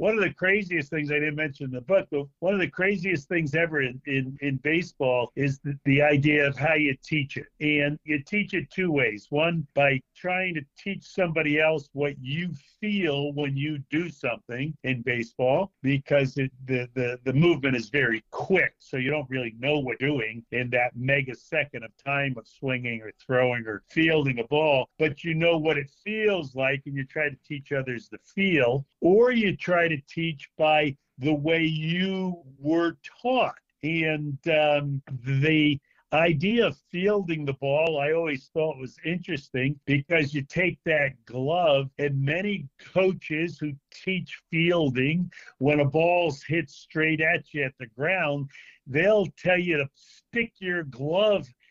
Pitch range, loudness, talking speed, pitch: 135-170 Hz, -26 LUFS, 175 wpm, 150 Hz